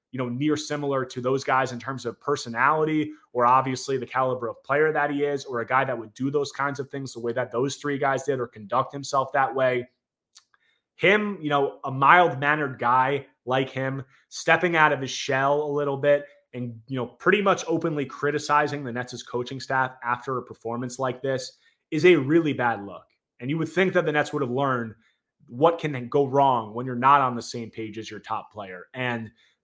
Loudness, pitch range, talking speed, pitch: -24 LUFS, 125-145 Hz, 215 wpm, 135 Hz